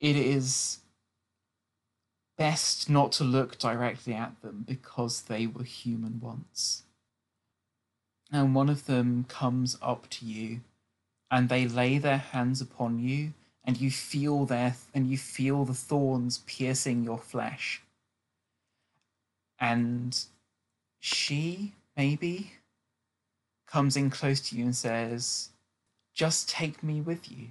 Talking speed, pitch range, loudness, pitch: 125 wpm, 115-135 Hz, -30 LUFS, 125 Hz